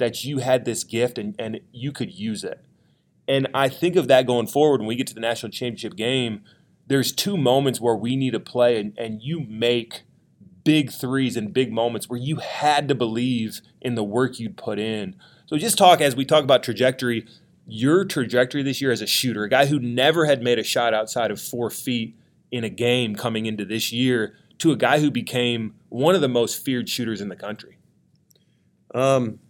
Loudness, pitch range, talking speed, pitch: -22 LUFS, 115-135 Hz, 210 wpm, 125 Hz